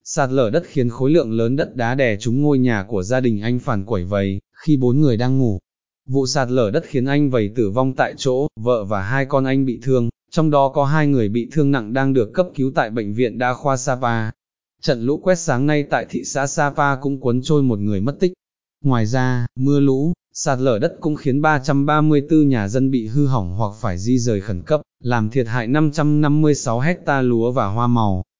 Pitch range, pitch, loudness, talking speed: 120-145 Hz, 130 Hz, -19 LUFS, 225 wpm